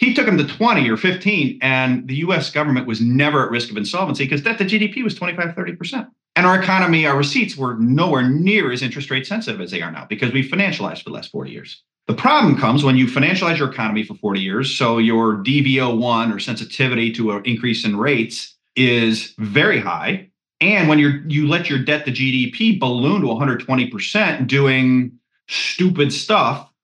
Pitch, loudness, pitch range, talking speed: 140 Hz, -17 LUFS, 125-180 Hz, 205 wpm